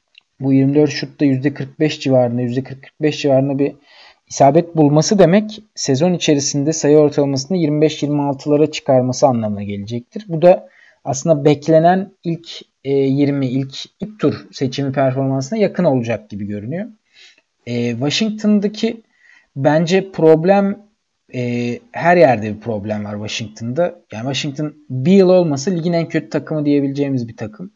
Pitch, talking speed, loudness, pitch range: 145 Hz, 125 wpm, -16 LUFS, 130-170 Hz